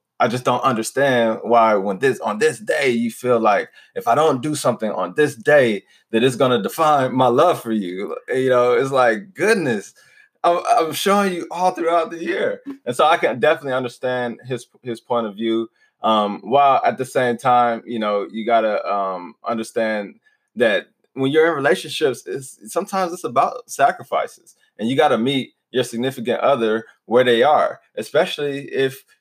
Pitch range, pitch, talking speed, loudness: 115-170 Hz, 130 Hz, 180 wpm, -19 LUFS